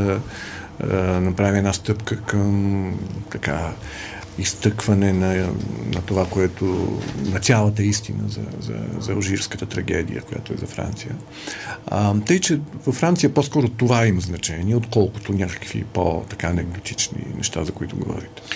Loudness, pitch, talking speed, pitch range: -22 LUFS, 100 Hz, 130 wpm, 95-110 Hz